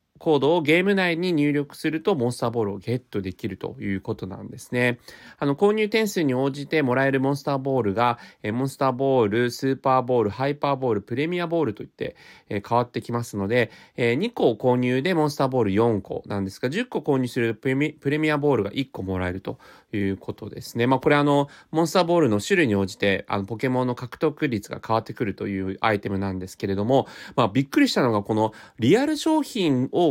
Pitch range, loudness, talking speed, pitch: 110-145 Hz, -23 LUFS, 435 characters per minute, 125 Hz